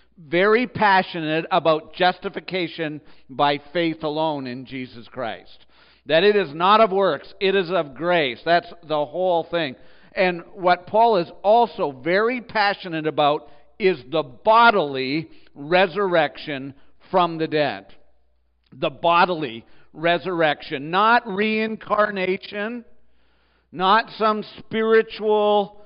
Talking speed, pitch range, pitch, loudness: 110 wpm, 150-200 Hz, 170 Hz, -21 LUFS